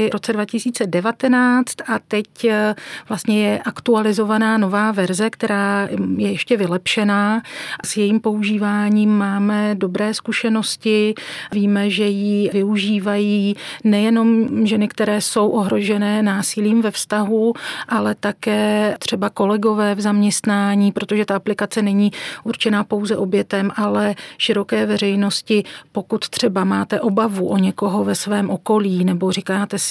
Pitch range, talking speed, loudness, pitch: 200-220 Hz, 120 wpm, -18 LUFS, 210 Hz